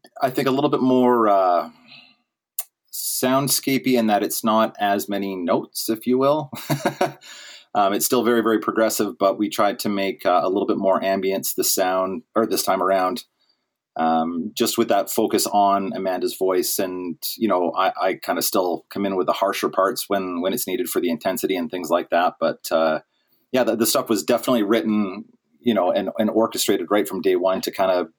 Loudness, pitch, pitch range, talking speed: -21 LUFS, 110 Hz, 95-125 Hz, 200 wpm